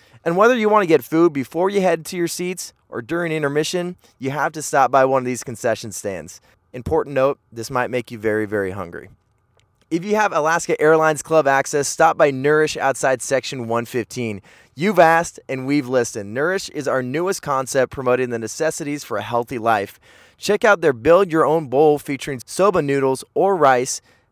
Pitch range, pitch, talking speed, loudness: 125-165 Hz, 140 Hz, 190 wpm, -19 LUFS